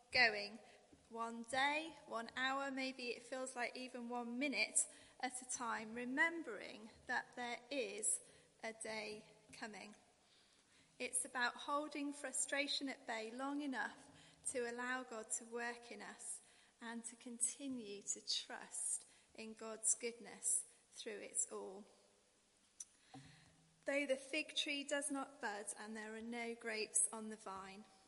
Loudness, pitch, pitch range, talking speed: -43 LUFS, 245 Hz, 225-275 Hz, 135 wpm